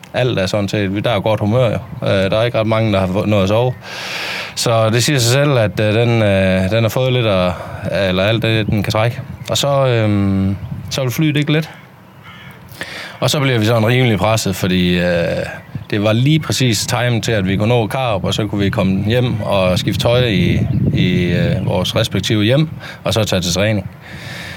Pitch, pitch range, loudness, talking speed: 110 Hz, 100-125 Hz, -15 LUFS, 215 wpm